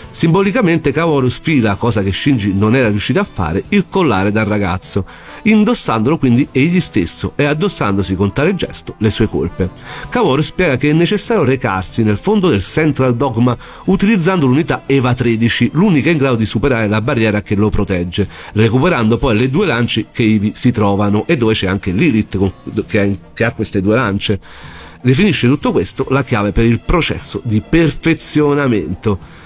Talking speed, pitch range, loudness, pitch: 165 wpm, 105-150 Hz, -14 LUFS, 120 Hz